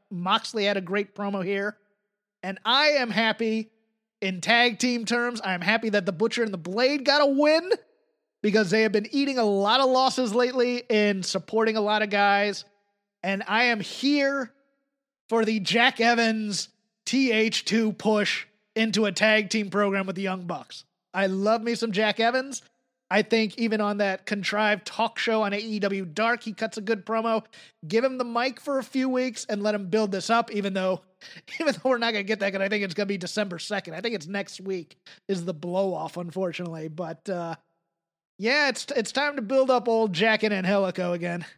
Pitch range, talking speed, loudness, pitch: 200-235 Hz, 200 wpm, -25 LUFS, 215 Hz